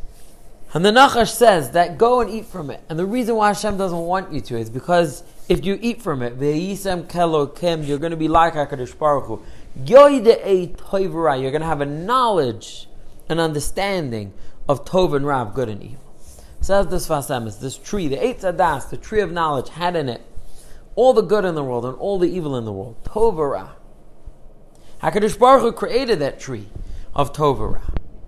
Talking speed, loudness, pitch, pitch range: 185 wpm, -19 LUFS, 165 Hz, 135-195 Hz